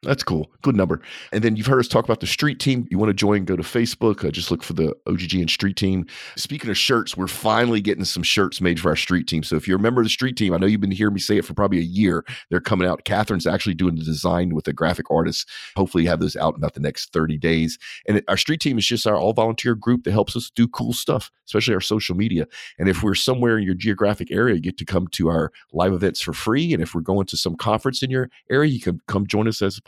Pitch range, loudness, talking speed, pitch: 90-110 Hz, -21 LUFS, 285 wpm, 100 Hz